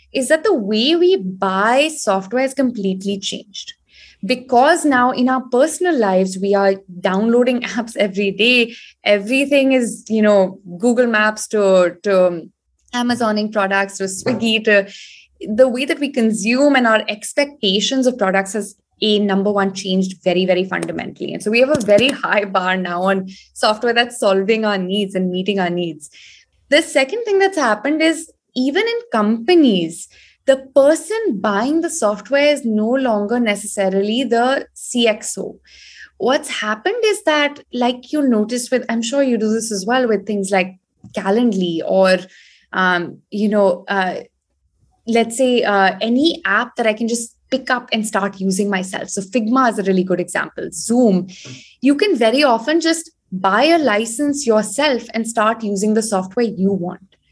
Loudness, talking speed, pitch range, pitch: -17 LUFS, 160 wpm, 195-260 Hz, 220 Hz